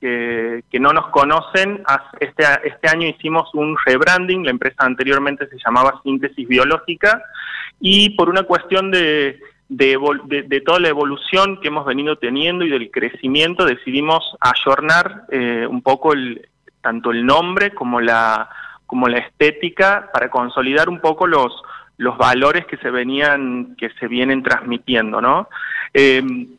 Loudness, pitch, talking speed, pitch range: -16 LUFS, 140 Hz, 150 wpm, 125-160 Hz